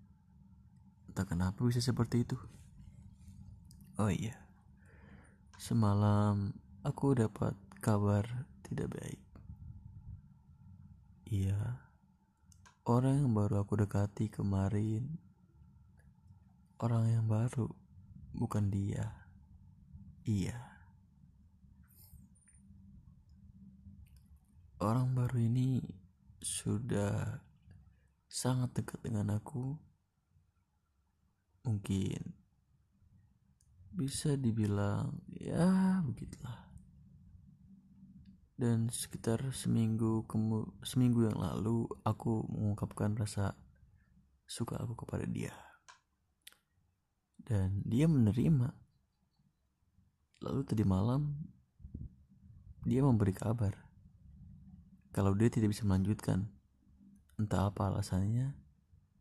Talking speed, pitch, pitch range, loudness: 70 wpm, 105 Hz, 95-115 Hz, -35 LUFS